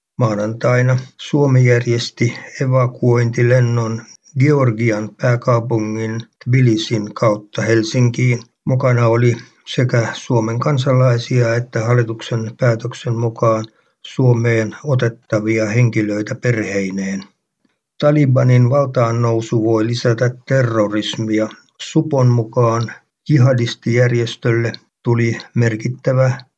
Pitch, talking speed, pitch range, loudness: 120 Hz, 75 wpm, 115-125 Hz, -16 LUFS